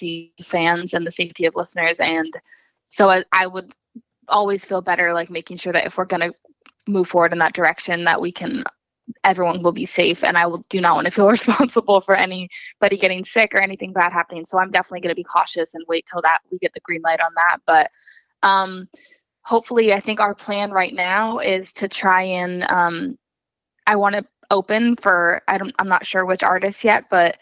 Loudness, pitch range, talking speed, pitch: -18 LUFS, 170-200 Hz, 210 wpm, 185 Hz